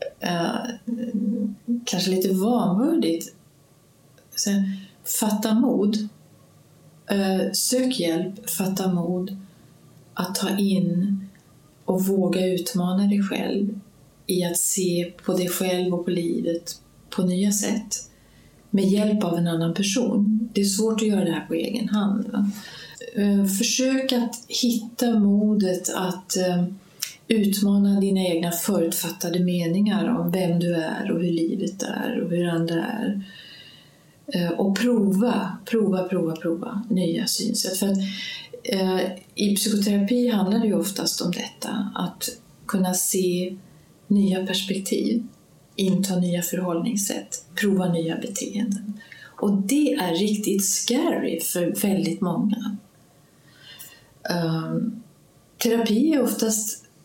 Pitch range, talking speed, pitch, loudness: 175-220 Hz, 115 wpm, 195 Hz, -23 LUFS